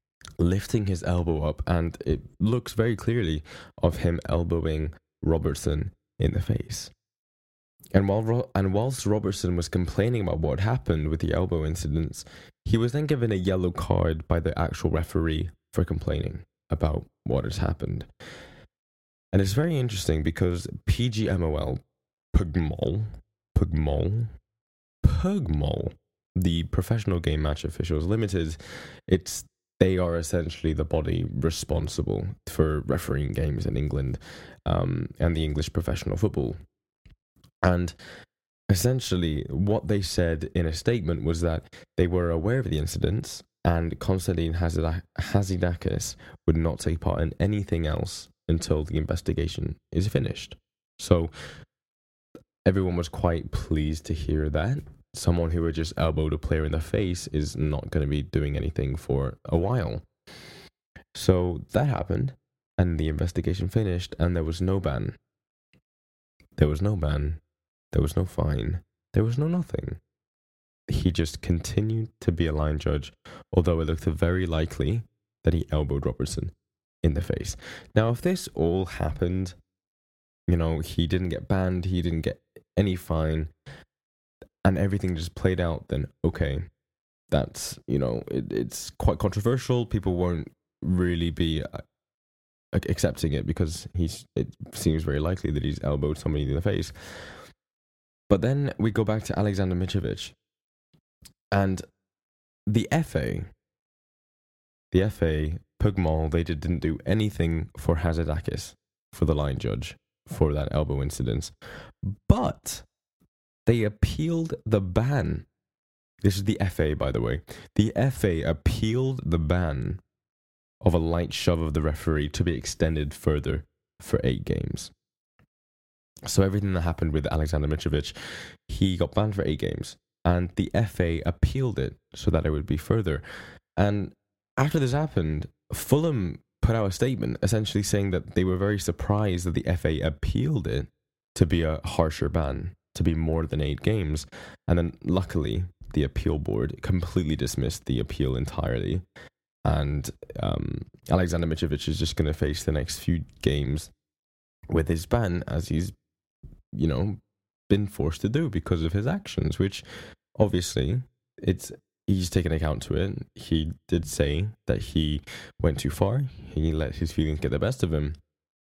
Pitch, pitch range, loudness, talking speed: 85 Hz, 75-100 Hz, -27 LUFS, 145 wpm